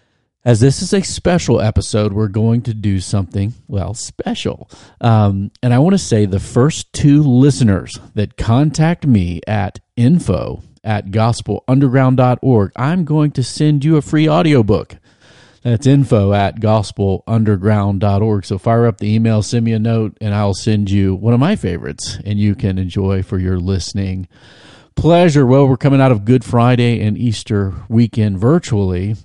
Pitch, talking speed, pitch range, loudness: 110 Hz, 160 wpm, 100-130 Hz, -15 LUFS